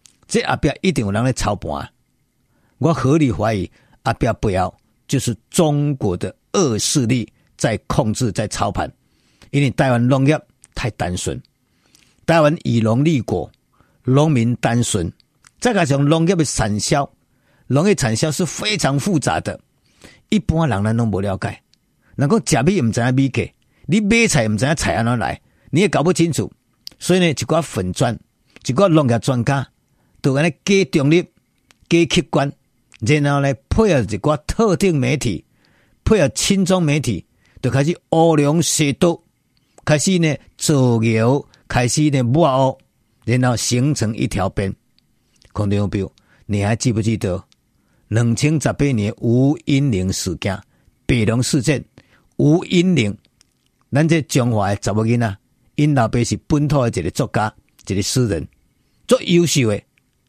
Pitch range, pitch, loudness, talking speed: 110-155 Hz, 130 Hz, -18 LUFS, 220 characters per minute